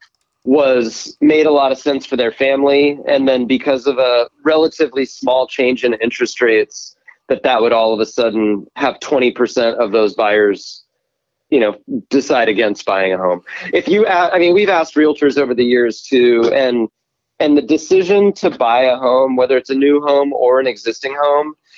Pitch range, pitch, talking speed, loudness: 120-145 Hz, 130 Hz, 185 wpm, -14 LUFS